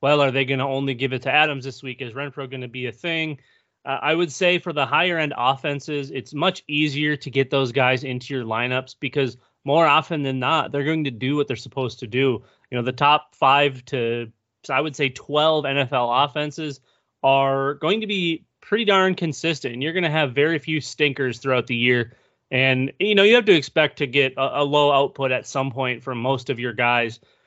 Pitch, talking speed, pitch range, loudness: 140 Hz, 225 wpm, 130-150 Hz, -21 LUFS